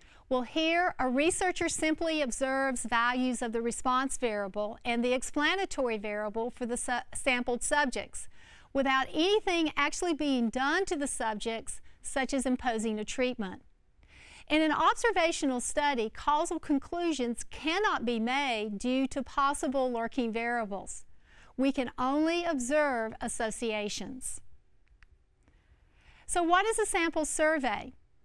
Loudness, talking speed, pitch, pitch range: -30 LUFS, 125 wpm, 265 Hz, 240-310 Hz